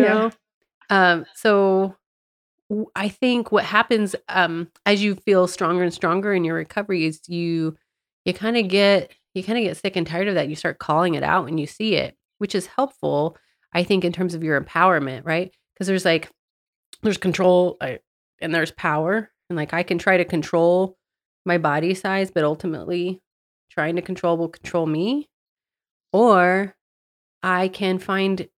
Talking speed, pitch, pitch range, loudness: 175 wpm, 180 Hz, 165-200 Hz, -21 LUFS